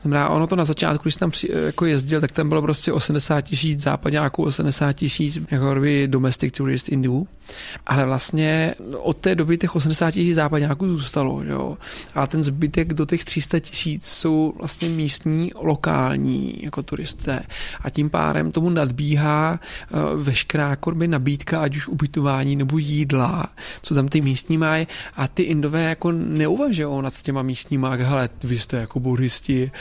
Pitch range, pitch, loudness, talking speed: 135-160 Hz, 150 Hz, -21 LUFS, 160 wpm